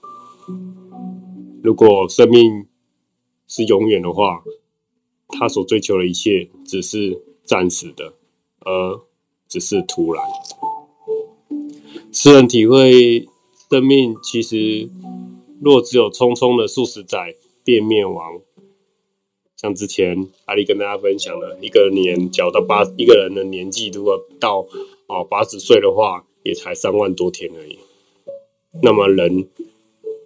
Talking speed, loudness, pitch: 175 characters per minute, -15 LUFS, 125 Hz